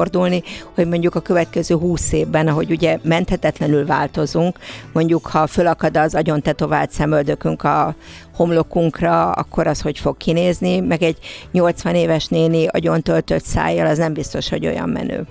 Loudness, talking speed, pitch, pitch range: -18 LUFS, 150 wpm, 165 Hz, 155-175 Hz